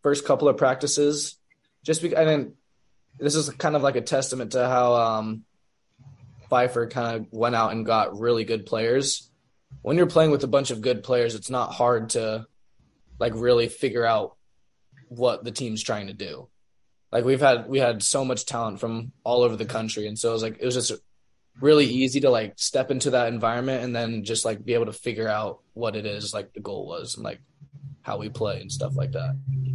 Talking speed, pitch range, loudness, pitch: 215 wpm, 115-135 Hz, -24 LUFS, 120 Hz